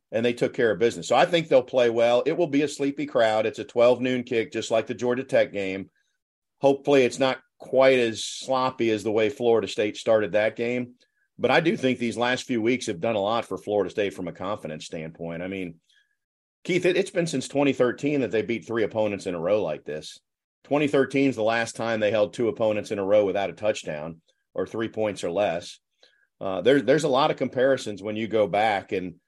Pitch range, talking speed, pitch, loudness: 110-135 Hz, 230 wpm, 120 Hz, -24 LUFS